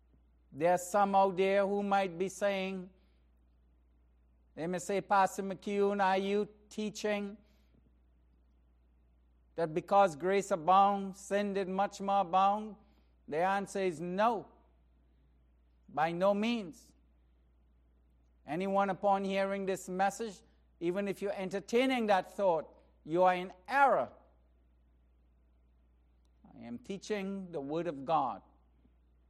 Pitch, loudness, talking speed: 185 Hz, -32 LUFS, 115 wpm